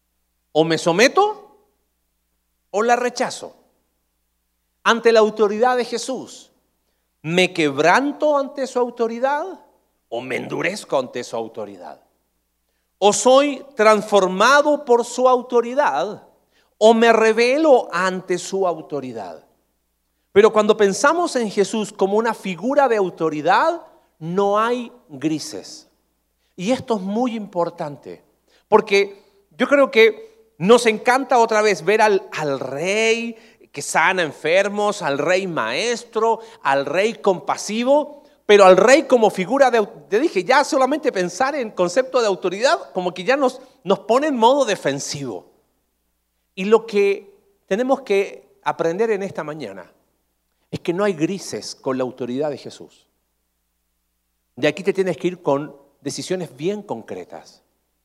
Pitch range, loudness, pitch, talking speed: 150-245 Hz, -18 LUFS, 205 Hz, 130 wpm